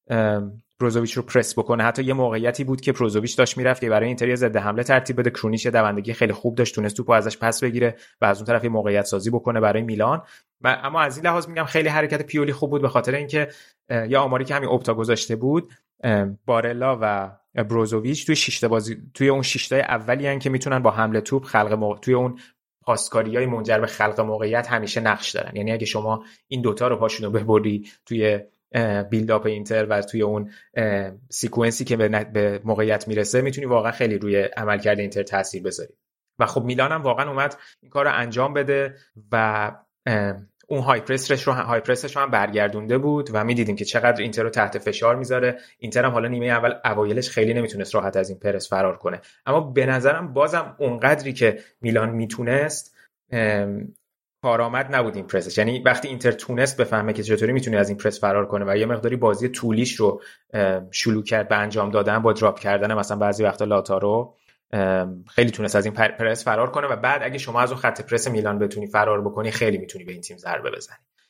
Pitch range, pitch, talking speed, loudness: 105-125 Hz, 115 Hz, 190 wpm, -22 LUFS